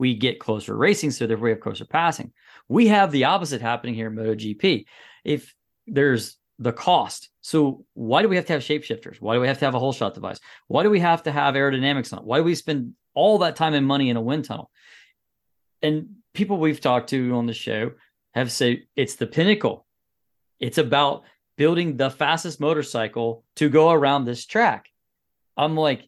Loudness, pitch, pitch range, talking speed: -22 LUFS, 140 Hz, 120-155 Hz, 205 wpm